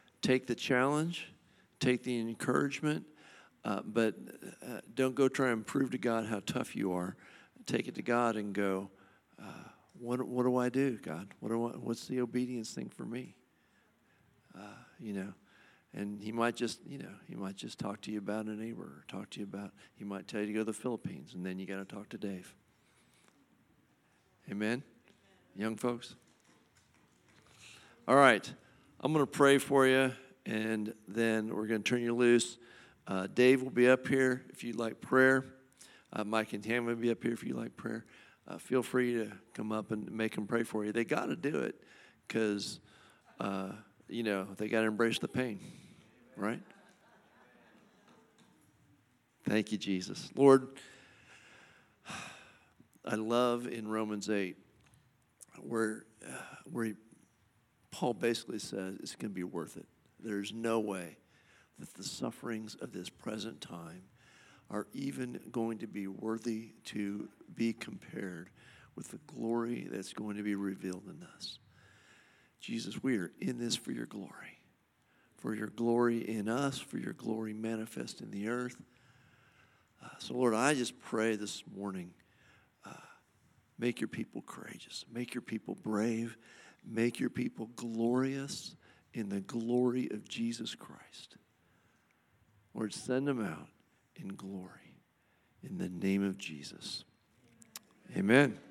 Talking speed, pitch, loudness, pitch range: 155 wpm, 115 Hz, -35 LUFS, 105-120 Hz